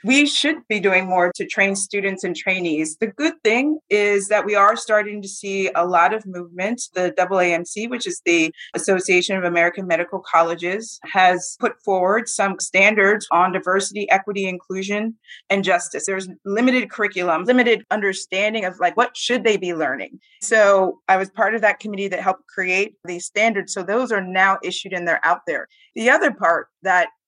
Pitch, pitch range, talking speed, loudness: 195 Hz, 185-220 Hz, 180 wpm, -19 LUFS